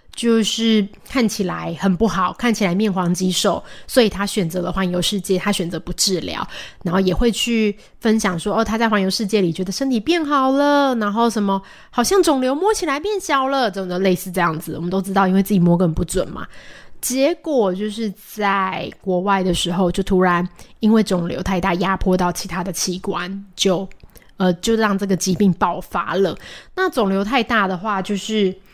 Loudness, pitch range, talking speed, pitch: -19 LUFS, 185-225 Hz, 285 characters per minute, 195 Hz